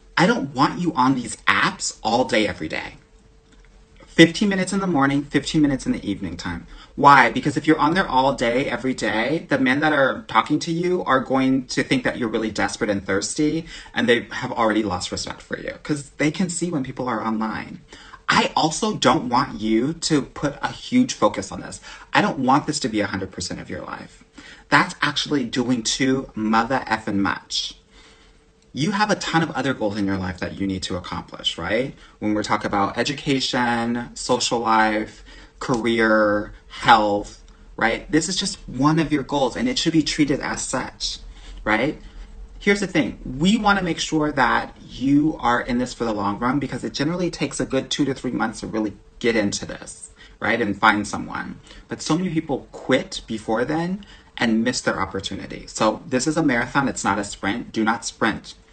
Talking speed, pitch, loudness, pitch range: 195 wpm, 130 Hz, -21 LUFS, 110-155 Hz